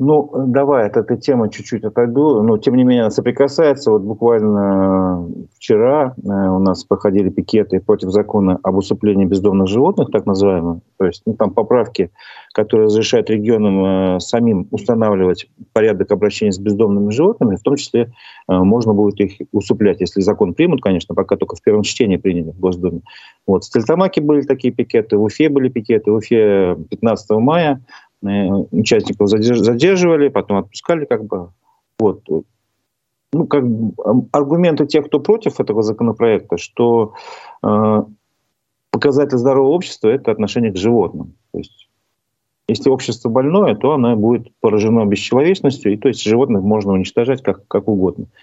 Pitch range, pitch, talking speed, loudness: 100-125 Hz, 110 Hz, 150 wpm, -15 LUFS